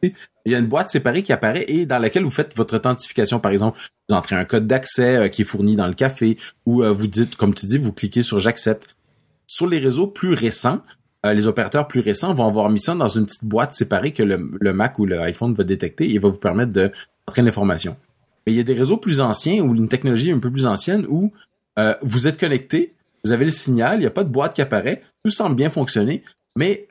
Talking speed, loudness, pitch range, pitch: 235 wpm, -19 LUFS, 105-140 Hz, 120 Hz